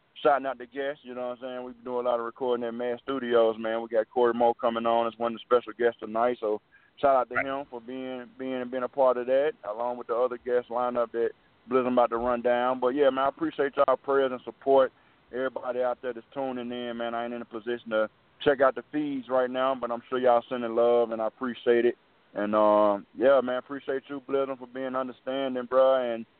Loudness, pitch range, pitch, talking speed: -27 LUFS, 120-130 Hz, 125 Hz, 250 wpm